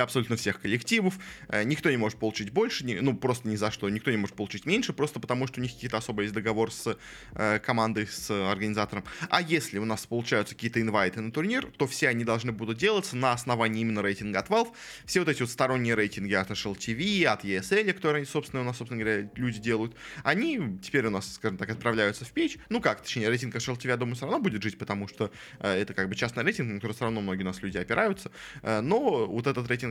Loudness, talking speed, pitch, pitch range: -29 LUFS, 235 wpm, 115 Hz, 105-135 Hz